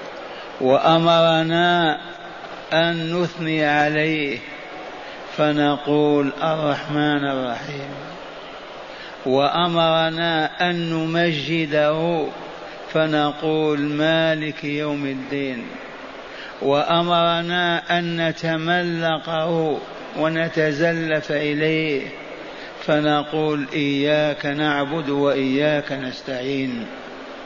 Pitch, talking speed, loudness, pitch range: 155 Hz, 50 wpm, -20 LUFS, 145-165 Hz